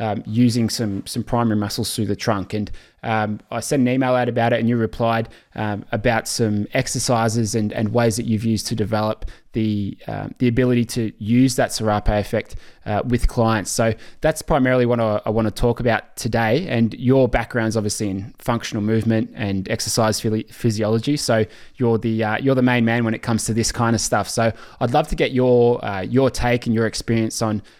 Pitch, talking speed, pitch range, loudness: 115 Hz, 210 wpm, 110-120 Hz, -20 LUFS